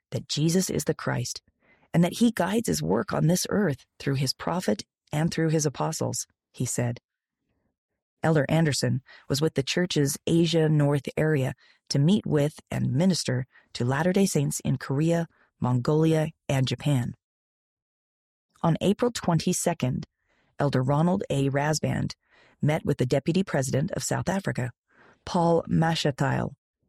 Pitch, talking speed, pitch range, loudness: 150 Hz, 140 wpm, 135-170 Hz, -26 LUFS